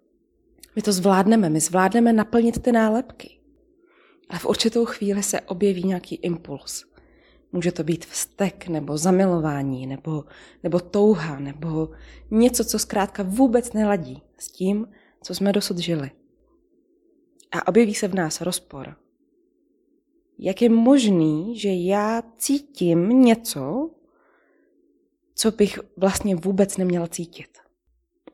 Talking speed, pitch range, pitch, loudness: 120 wpm, 175-245 Hz, 205 Hz, -22 LUFS